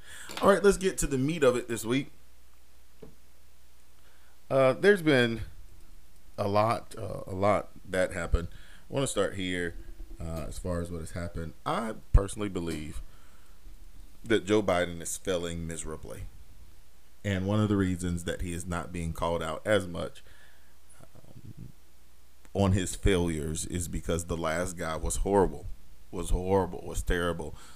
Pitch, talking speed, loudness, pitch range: 85 Hz, 155 wpm, -30 LUFS, 75-95 Hz